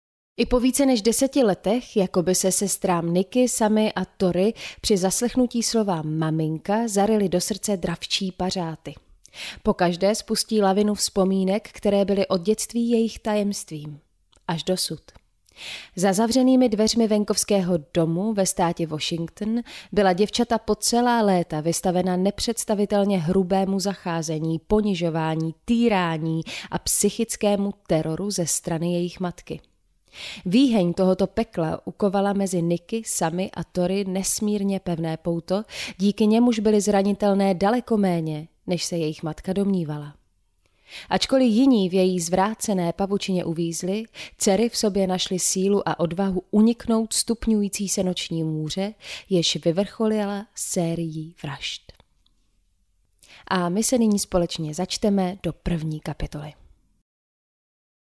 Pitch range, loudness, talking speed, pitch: 170-215 Hz, -23 LUFS, 120 wpm, 190 Hz